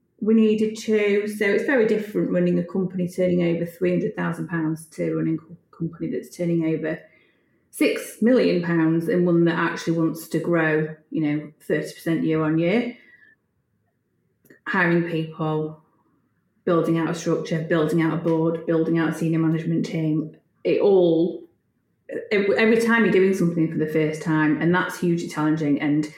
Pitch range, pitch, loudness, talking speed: 160-180 Hz, 165 Hz, -22 LUFS, 160 wpm